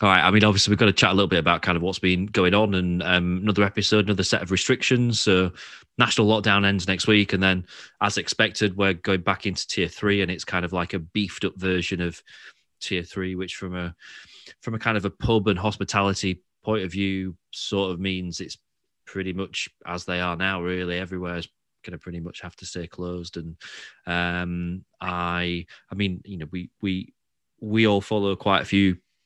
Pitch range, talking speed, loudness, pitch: 90-100 Hz, 215 wpm, -23 LUFS, 95 Hz